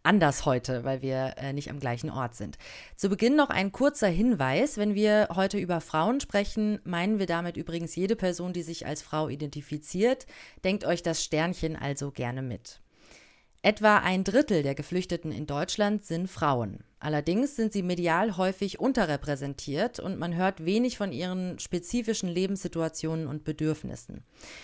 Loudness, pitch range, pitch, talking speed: -28 LUFS, 150-205 Hz, 175 Hz, 160 wpm